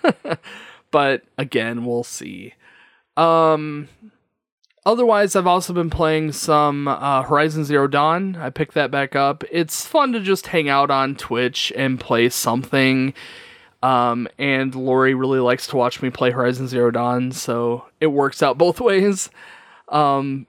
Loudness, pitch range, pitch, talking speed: -19 LUFS, 125-160 Hz, 140 Hz, 145 wpm